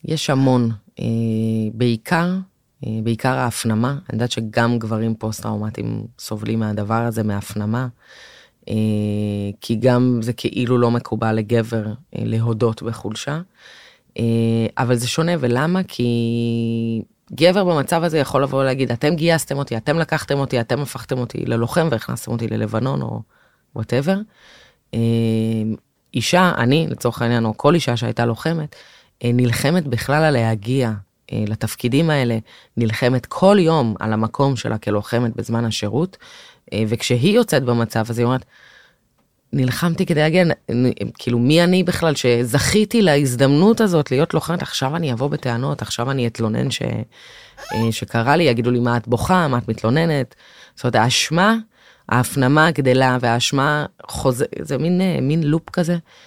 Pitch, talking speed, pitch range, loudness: 125 Hz, 130 wpm, 115-150 Hz, -19 LUFS